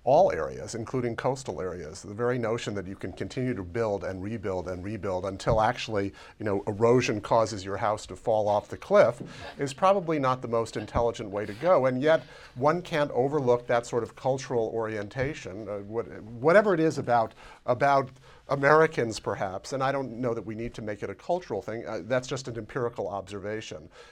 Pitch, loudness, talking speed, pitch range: 115 Hz, -28 LUFS, 195 wpm, 105-135 Hz